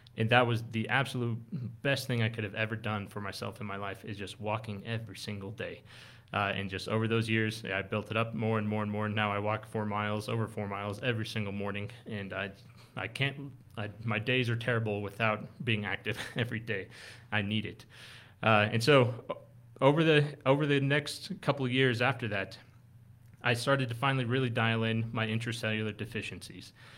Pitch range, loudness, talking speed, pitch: 105-125 Hz, -32 LUFS, 200 wpm, 115 Hz